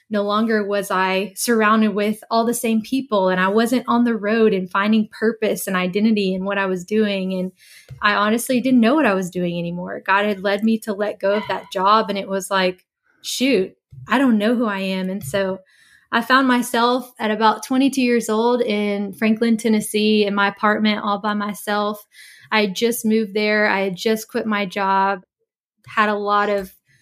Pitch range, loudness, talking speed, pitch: 195-225 Hz, -19 LUFS, 200 wpm, 210 Hz